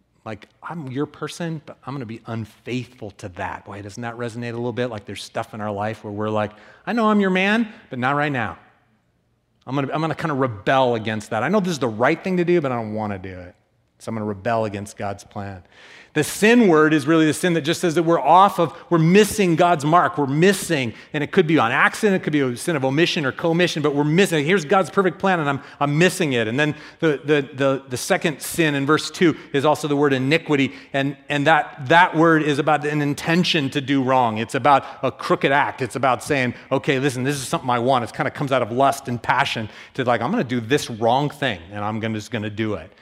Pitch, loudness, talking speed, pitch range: 140 Hz, -20 LUFS, 255 wpm, 115-165 Hz